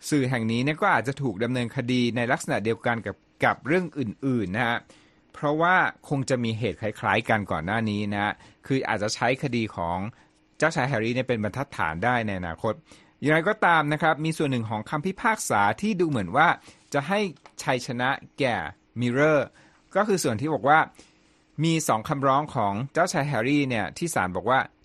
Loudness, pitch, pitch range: -25 LUFS, 125 Hz, 110-150 Hz